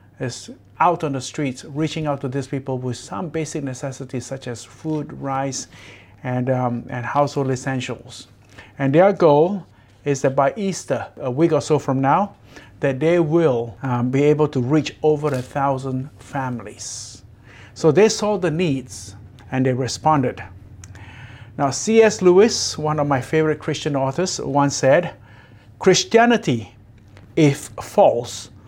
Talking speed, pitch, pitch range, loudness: 145 wpm, 135 Hz, 115-150 Hz, -20 LUFS